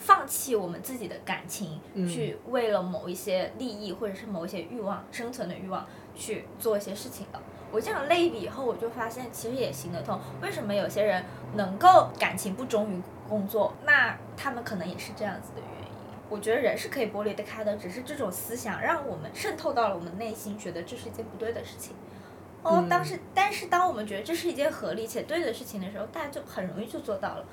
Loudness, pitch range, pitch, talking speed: -29 LUFS, 195-260 Hz, 215 Hz, 340 characters per minute